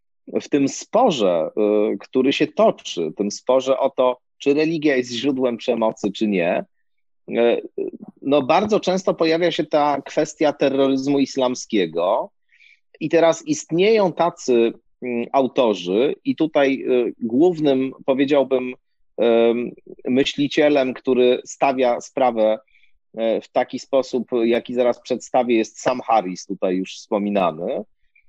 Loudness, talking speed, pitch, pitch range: -20 LUFS, 110 wpm, 135 Hz, 120-155 Hz